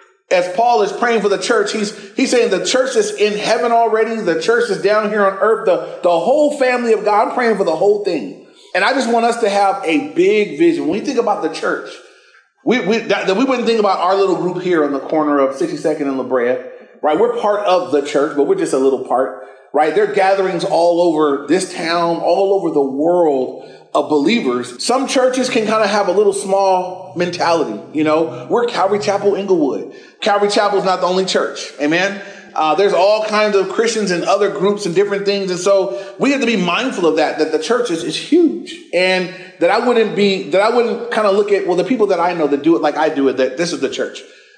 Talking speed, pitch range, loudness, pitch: 240 wpm, 175-240 Hz, -15 LUFS, 200 Hz